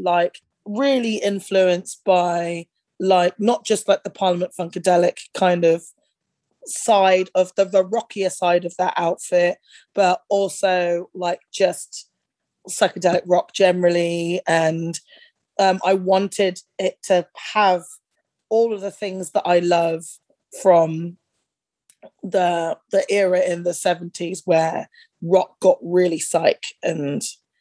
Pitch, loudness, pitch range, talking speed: 185 Hz, -20 LUFS, 175-195 Hz, 120 wpm